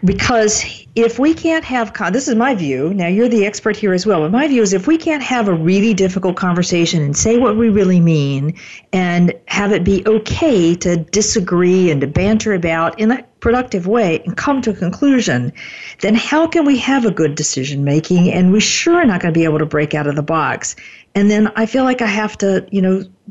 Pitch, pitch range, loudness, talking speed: 200 Hz, 175-230 Hz, -15 LUFS, 225 wpm